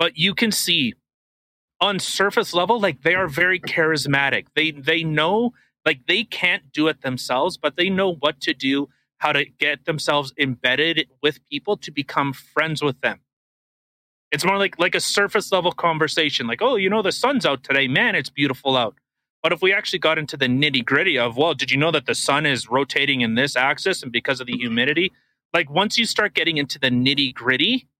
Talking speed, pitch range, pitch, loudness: 200 wpm, 140-185 Hz, 155 Hz, -20 LUFS